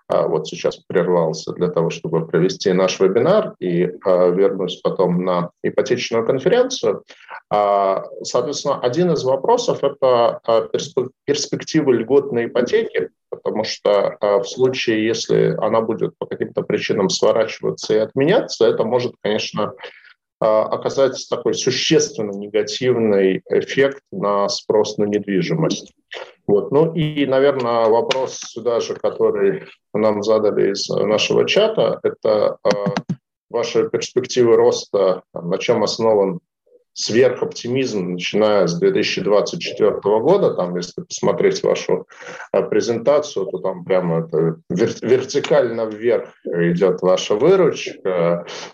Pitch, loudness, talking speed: 390 Hz, -18 LUFS, 105 wpm